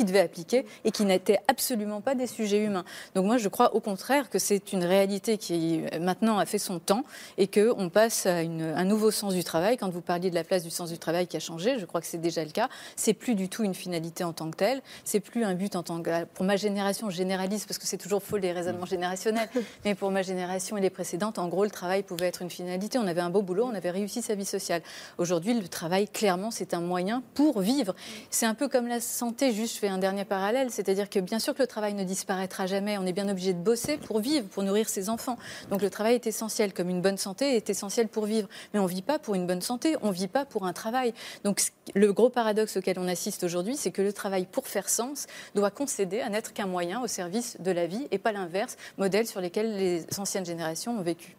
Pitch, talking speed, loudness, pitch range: 200 Hz, 255 wpm, -29 LUFS, 185-225 Hz